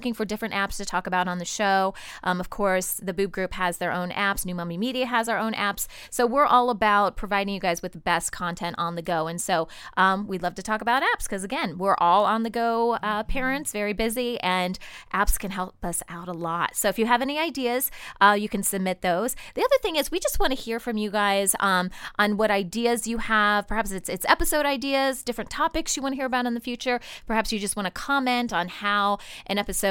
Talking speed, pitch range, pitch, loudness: 245 wpm, 185-245 Hz, 210 Hz, -25 LUFS